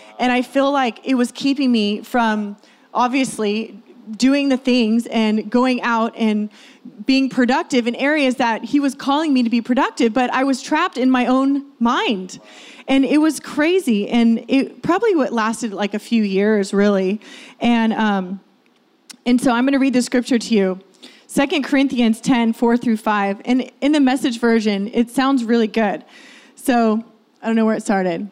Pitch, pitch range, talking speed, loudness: 245 Hz, 220-265 Hz, 180 wpm, -18 LUFS